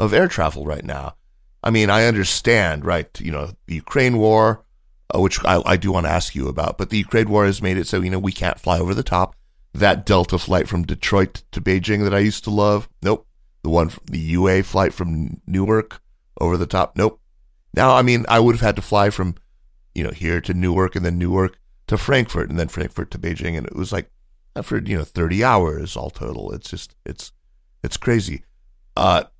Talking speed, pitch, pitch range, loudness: 220 wpm, 95 Hz, 85-105 Hz, -19 LUFS